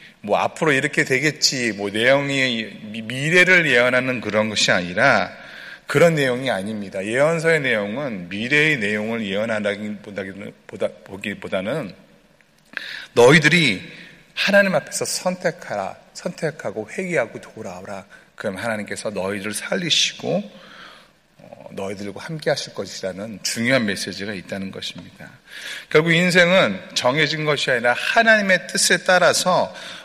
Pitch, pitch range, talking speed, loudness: 130 Hz, 105-165 Hz, 300 characters per minute, -19 LUFS